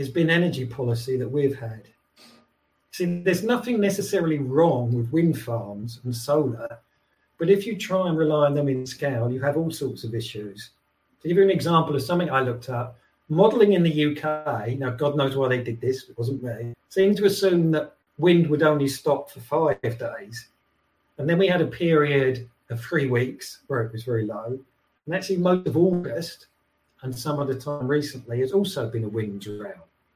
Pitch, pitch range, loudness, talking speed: 145 Hz, 125-170 Hz, -24 LUFS, 190 wpm